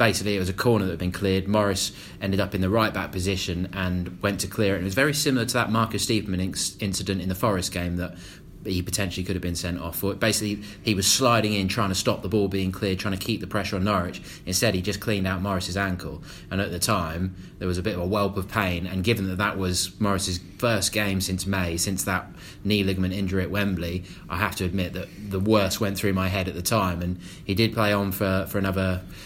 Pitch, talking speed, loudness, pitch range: 95 Hz, 250 wpm, -25 LUFS, 90-105 Hz